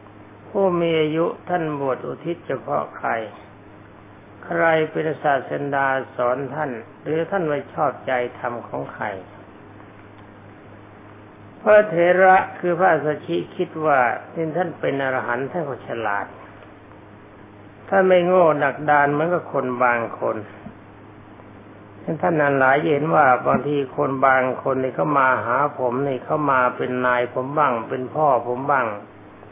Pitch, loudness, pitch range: 130 Hz, -20 LUFS, 105-155 Hz